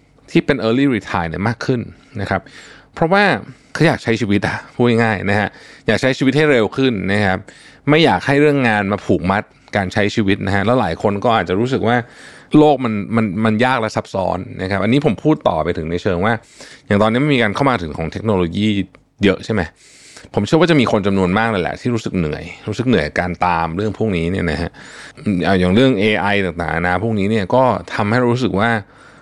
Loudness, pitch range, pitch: -17 LUFS, 95-125 Hz, 110 Hz